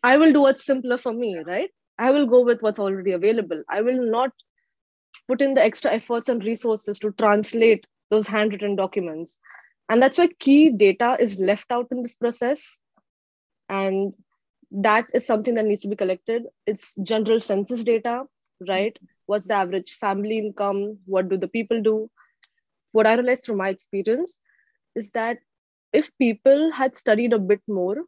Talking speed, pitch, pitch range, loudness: 170 wpm, 225 Hz, 205-250 Hz, -22 LUFS